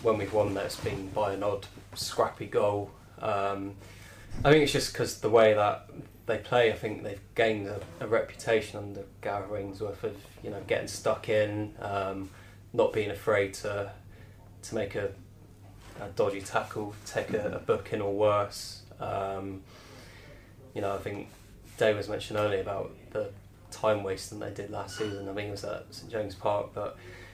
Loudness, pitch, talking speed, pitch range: -31 LUFS, 100 Hz, 180 wpm, 100-105 Hz